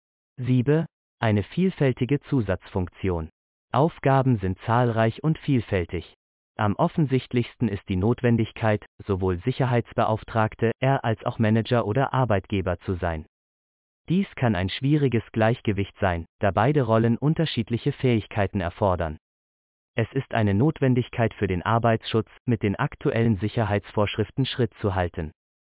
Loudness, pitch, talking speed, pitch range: -24 LUFS, 115 Hz, 115 wpm, 100-130 Hz